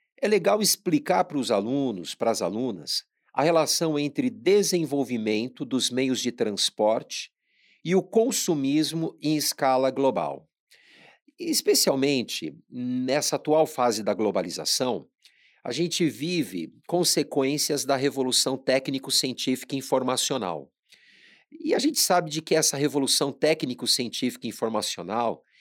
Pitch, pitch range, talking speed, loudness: 145 Hz, 130-170 Hz, 115 wpm, -25 LUFS